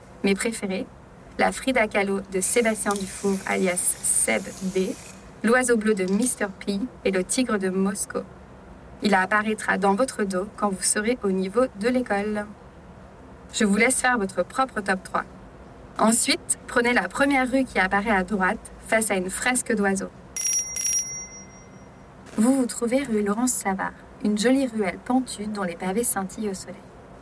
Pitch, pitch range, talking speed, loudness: 210 Hz, 190-245 Hz, 155 wpm, -23 LUFS